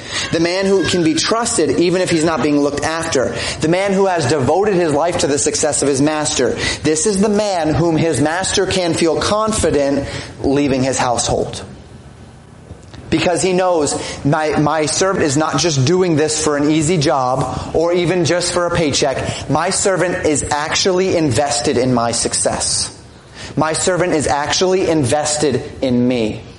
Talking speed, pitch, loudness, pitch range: 170 wpm, 155 Hz, -15 LUFS, 140-175 Hz